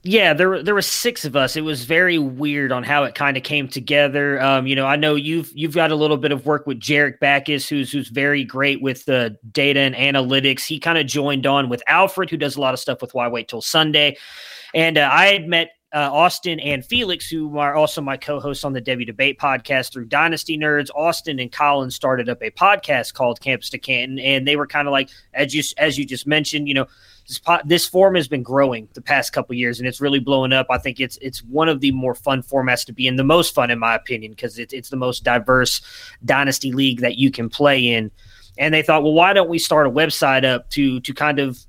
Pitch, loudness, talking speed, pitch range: 140 Hz, -18 LUFS, 250 wpm, 130-155 Hz